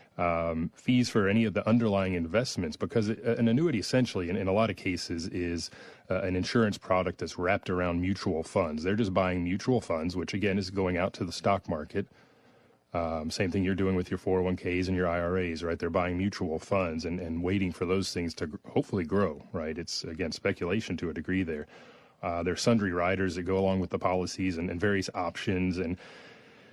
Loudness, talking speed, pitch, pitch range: -30 LUFS, 215 wpm, 95 Hz, 90-100 Hz